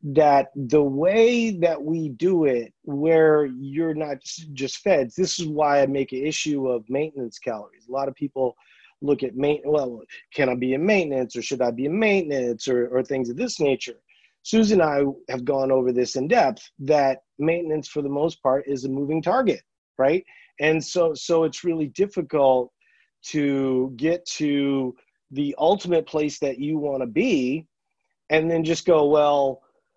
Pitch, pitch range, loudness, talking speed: 145 Hz, 135-160 Hz, -23 LUFS, 180 wpm